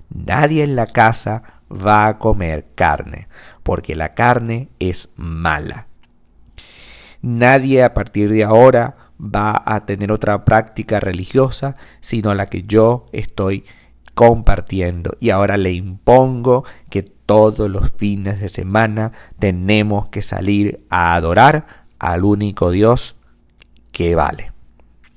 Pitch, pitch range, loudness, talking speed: 105 Hz, 90-115 Hz, -15 LUFS, 120 wpm